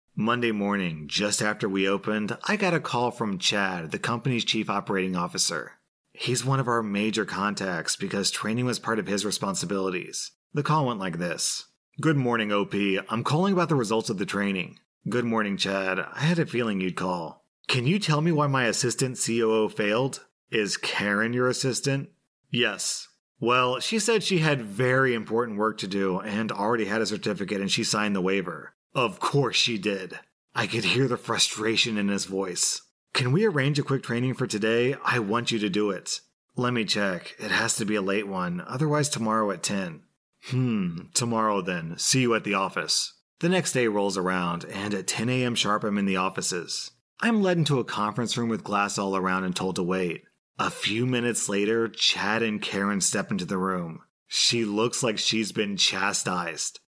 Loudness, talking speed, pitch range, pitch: -26 LUFS, 190 wpm, 100-125 Hz, 110 Hz